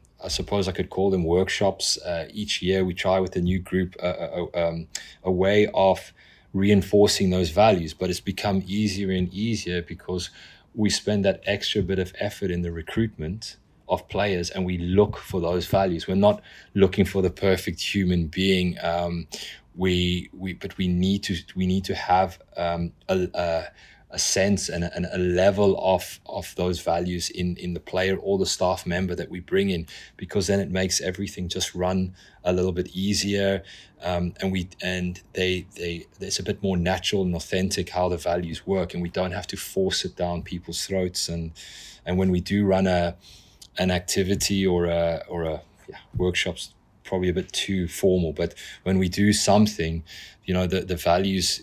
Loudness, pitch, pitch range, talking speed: -25 LUFS, 95 Hz, 90-95 Hz, 190 wpm